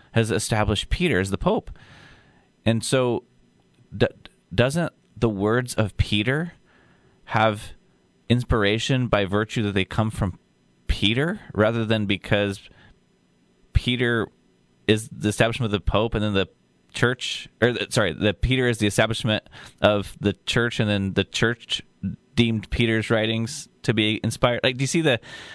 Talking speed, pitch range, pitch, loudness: 150 wpm, 100-120 Hz, 110 Hz, -23 LUFS